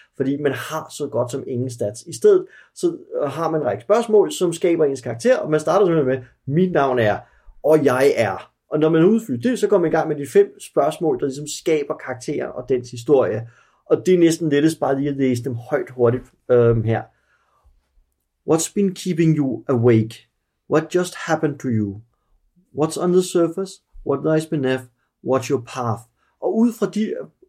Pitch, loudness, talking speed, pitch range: 150 Hz, -20 LUFS, 195 wpm, 125-180 Hz